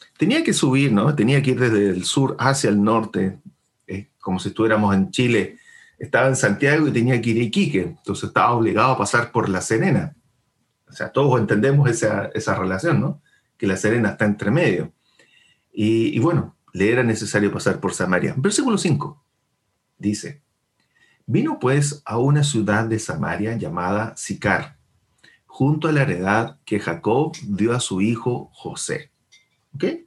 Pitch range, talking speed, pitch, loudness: 105-135 Hz, 165 wpm, 120 Hz, -20 LUFS